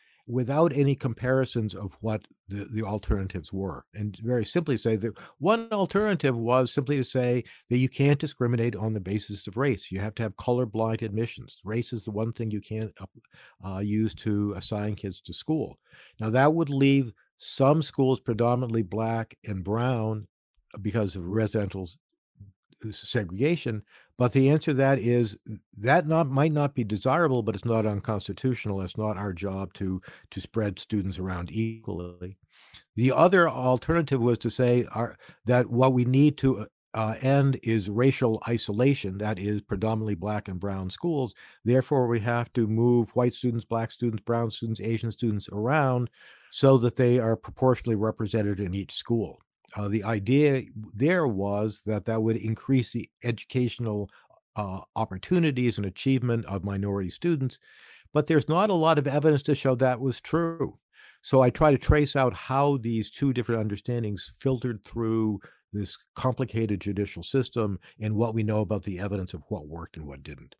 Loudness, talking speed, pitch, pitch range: -27 LUFS, 165 wpm, 115 Hz, 105-130 Hz